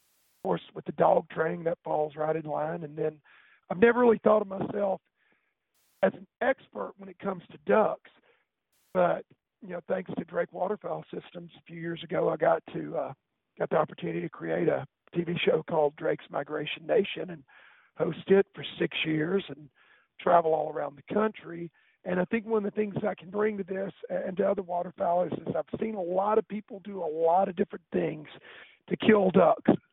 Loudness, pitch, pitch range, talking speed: -29 LUFS, 180 Hz, 160-200 Hz, 200 wpm